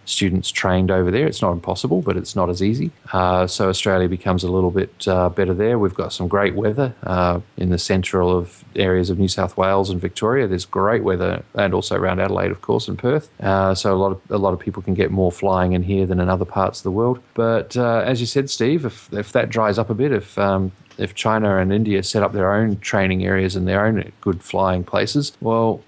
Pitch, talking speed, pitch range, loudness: 95 Hz, 240 wpm, 95-110 Hz, -19 LUFS